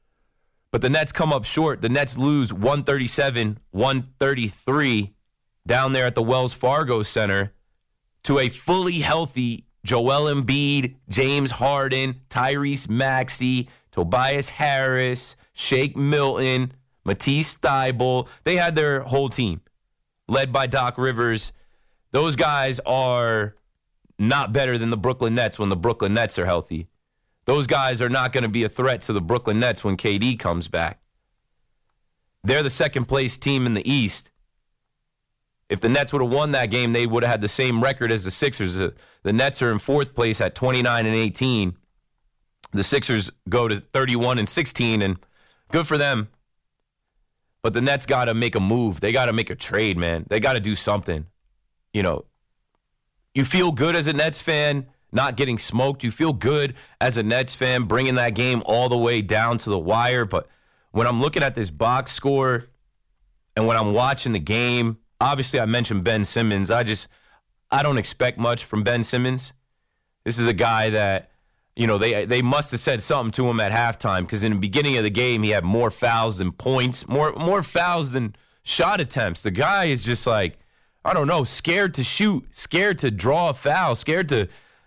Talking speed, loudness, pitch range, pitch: 180 wpm, -22 LUFS, 110-135 Hz, 125 Hz